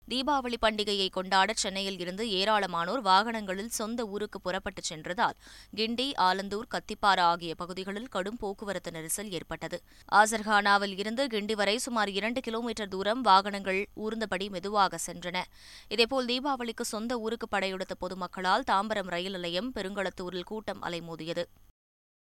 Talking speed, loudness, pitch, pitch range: 120 wpm, -30 LUFS, 200 Hz, 180-220 Hz